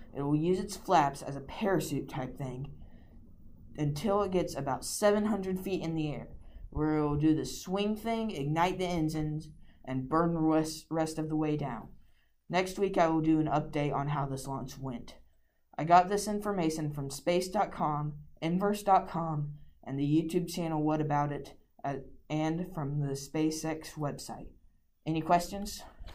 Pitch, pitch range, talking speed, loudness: 155 Hz, 140-175 Hz, 165 wpm, -32 LUFS